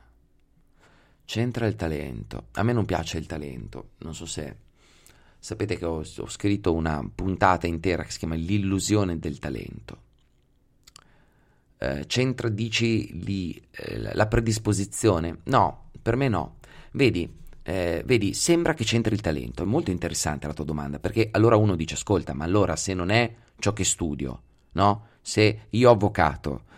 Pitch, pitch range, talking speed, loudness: 95 Hz, 80-110 Hz, 155 wpm, -25 LUFS